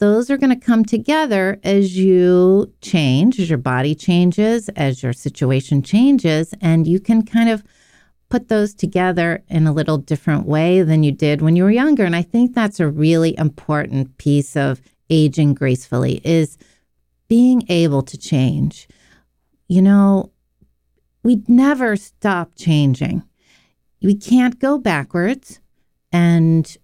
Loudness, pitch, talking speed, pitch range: -16 LUFS, 175 Hz, 145 wpm, 150-210 Hz